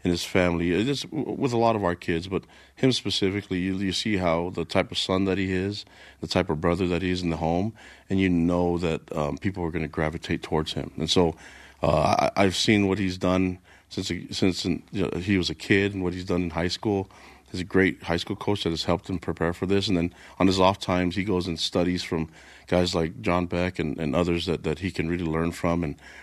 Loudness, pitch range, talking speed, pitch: -26 LUFS, 85-95 Hz, 250 wpm, 90 Hz